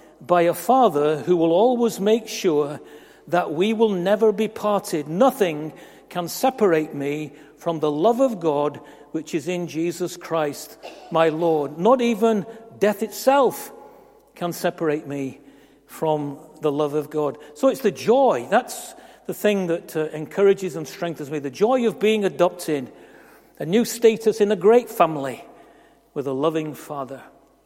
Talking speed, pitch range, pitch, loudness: 155 wpm, 150-215 Hz, 175 Hz, -21 LUFS